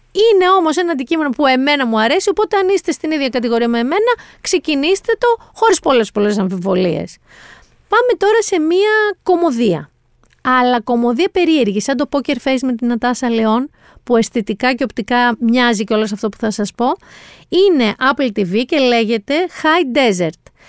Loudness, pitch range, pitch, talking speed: -15 LUFS, 235-355 Hz, 265 Hz, 170 wpm